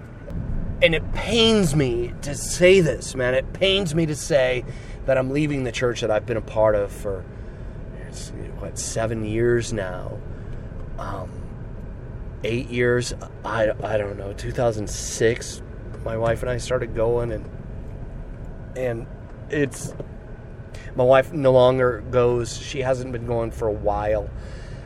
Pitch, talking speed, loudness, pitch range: 120 Hz, 140 wpm, -22 LUFS, 110-130 Hz